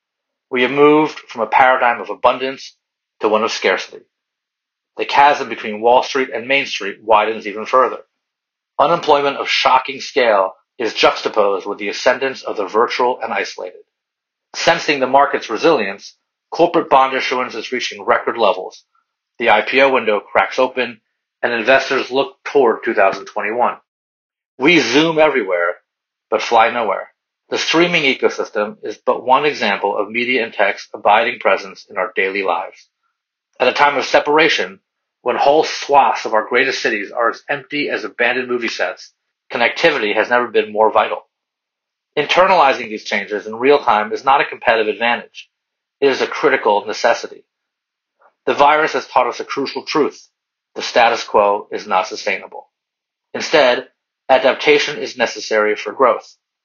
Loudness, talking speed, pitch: -16 LUFS, 150 wpm, 140 Hz